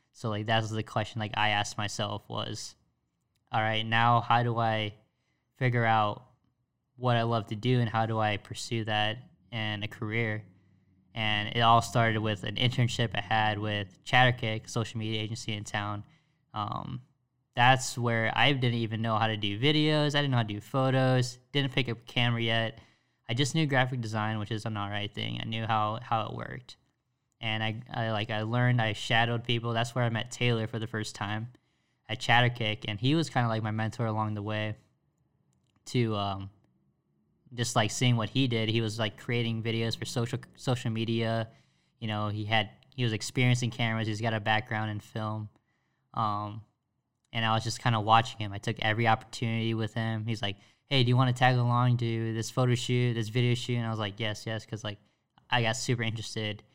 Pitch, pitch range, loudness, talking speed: 115 Hz, 110-125 Hz, -29 LUFS, 205 wpm